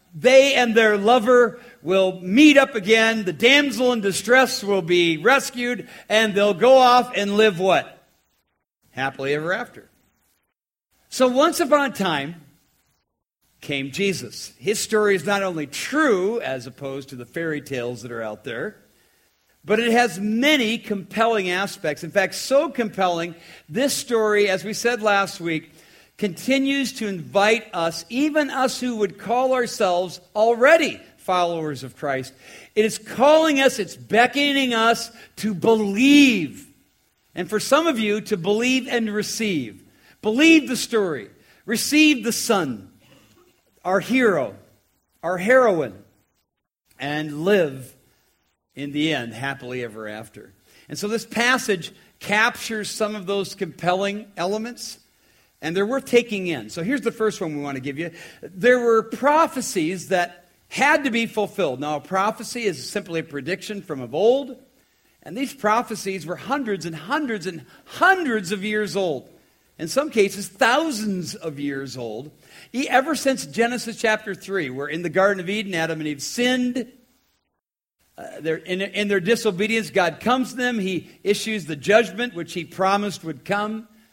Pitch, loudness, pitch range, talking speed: 205 Hz, -21 LUFS, 170-240 Hz, 150 wpm